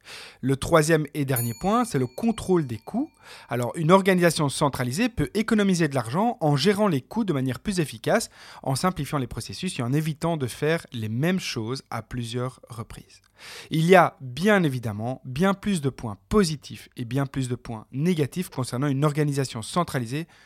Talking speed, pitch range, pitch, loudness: 180 wpm, 125-185 Hz, 145 Hz, -25 LUFS